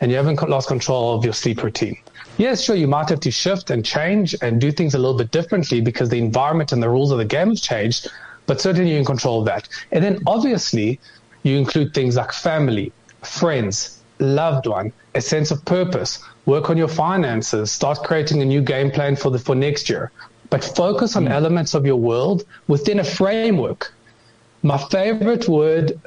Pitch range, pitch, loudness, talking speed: 120-165 Hz, 140 Hz, -19 LUFS, 195 wpm